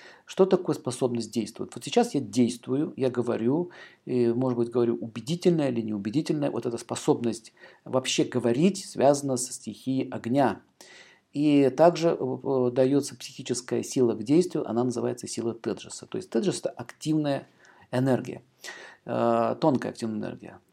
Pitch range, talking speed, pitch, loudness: 120-145 Hz, 135 wpm, 125 Hz, -27 LUFS